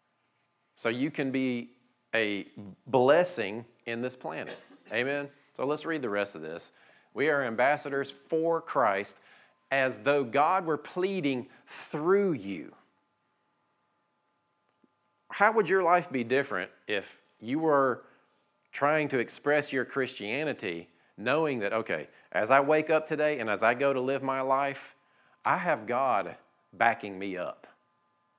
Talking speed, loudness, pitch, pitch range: 135 wpm, -29 LUFS, 140 Hz, 120-150 Hz